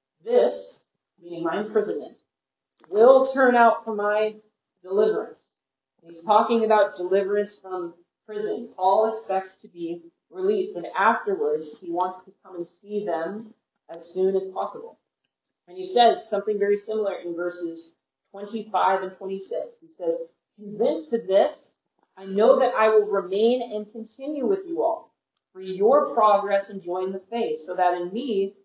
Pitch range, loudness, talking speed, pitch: 185-230 Hz, -23 LUFS, 155 wpm, 205 Hz